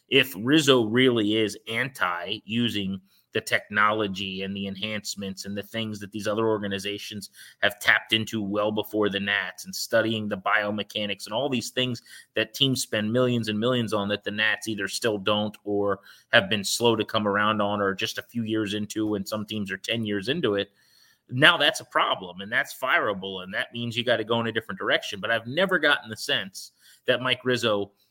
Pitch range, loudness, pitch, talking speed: 100-115 Hz, -25 LUFS, 105 Hz, 205 wpm